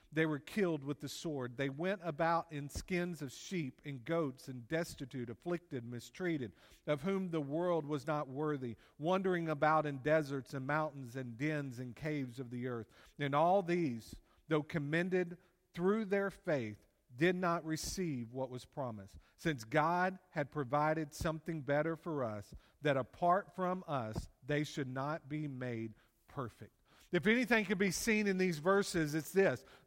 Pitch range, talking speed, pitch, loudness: 135-175 Hz, 165 wpm, 155 Hz, -37 LUFS